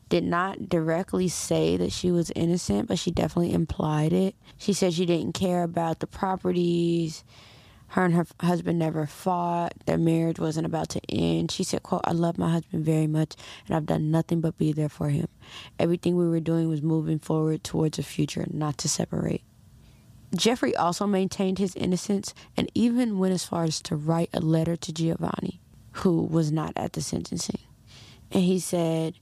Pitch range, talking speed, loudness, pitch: 155-180 Hz, 185 wpm, -26 LUFS, 165 Hz